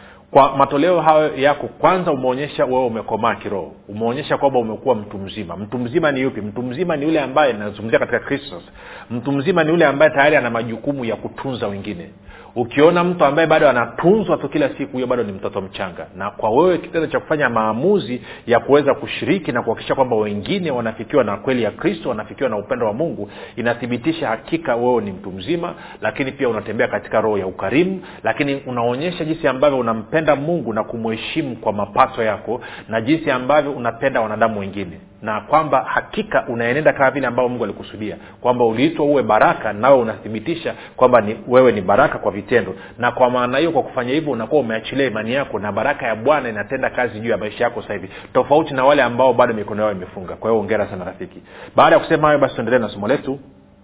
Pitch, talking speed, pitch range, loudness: 125 Hz, 190 wpm, 110-145 Hz, -18 LUFS